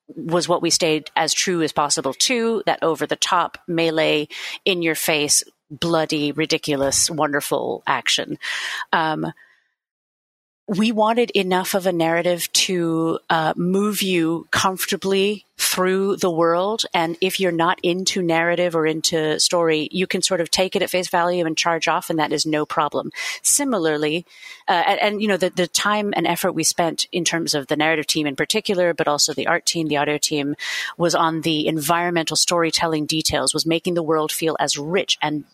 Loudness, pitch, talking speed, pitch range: -20 LUFS, 170 Hz, 175 wpm, 155-185 Hz